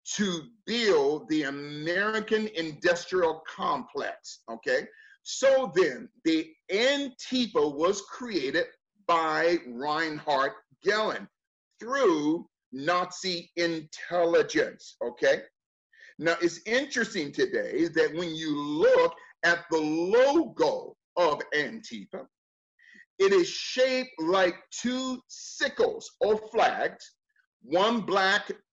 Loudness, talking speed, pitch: -27 LUFS, 90 wpm, 230 Hz